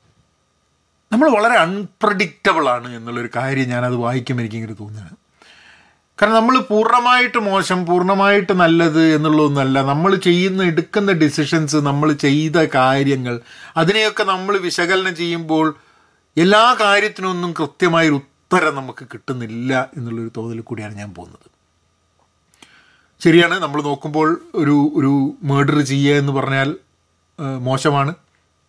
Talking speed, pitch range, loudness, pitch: 105 wpm, 125-180 Hz, -16 LUFS, 150 Hz